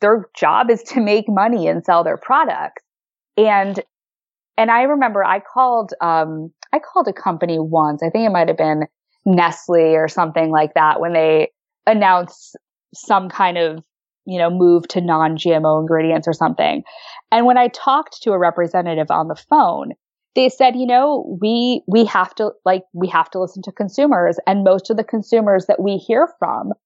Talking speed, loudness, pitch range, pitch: 185 wpm, -16 LUFS, 165-230 Hz, 190 Hz